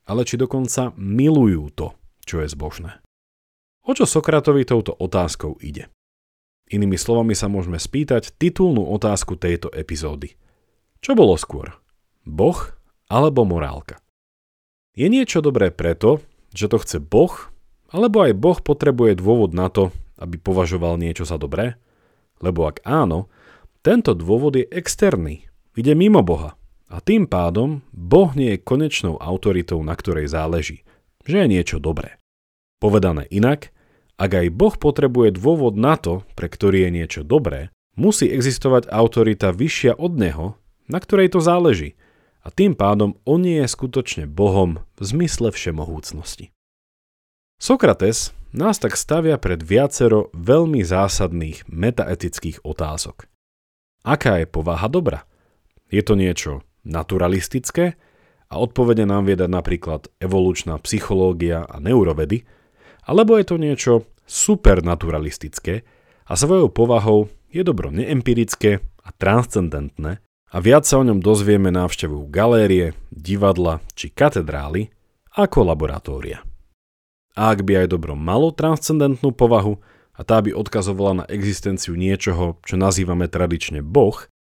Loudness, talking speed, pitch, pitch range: -18 LUFS, 130 wpm, 100 Hz, 85-125 Hz